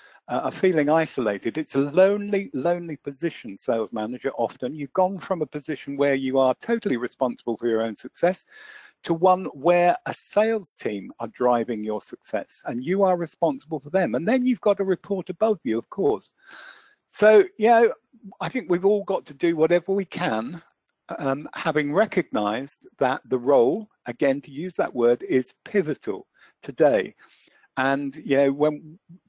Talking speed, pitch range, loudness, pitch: 170 wpm, 135-195 Hz, -24 LUFS, 170 Hz